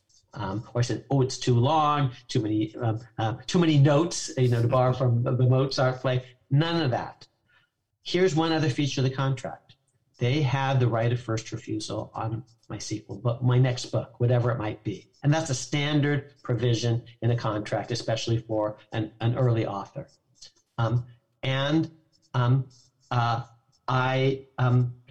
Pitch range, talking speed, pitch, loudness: 115-135 Hz, 170 wpm, 125 Hz, -26 LUFS